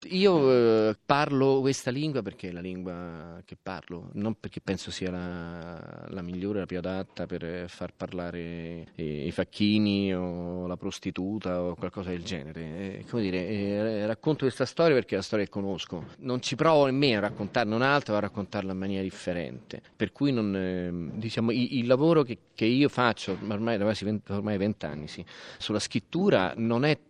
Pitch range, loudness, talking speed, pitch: 90-115 Hz, -28 LUFS, 185 wpm, 100 Hz